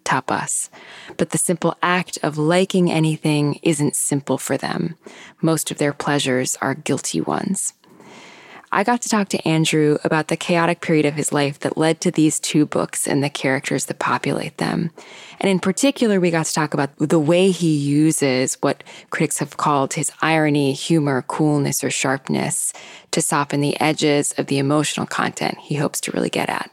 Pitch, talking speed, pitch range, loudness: 155 Hz, 180 wpm, 145-175 Hz, -19 LUFS